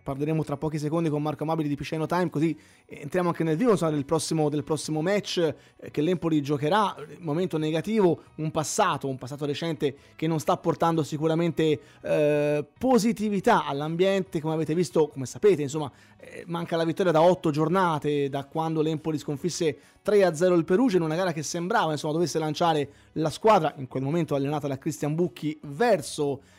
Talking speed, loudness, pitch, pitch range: 165 wpm, -26 LUFS, 155 Hz, 150-175 Hz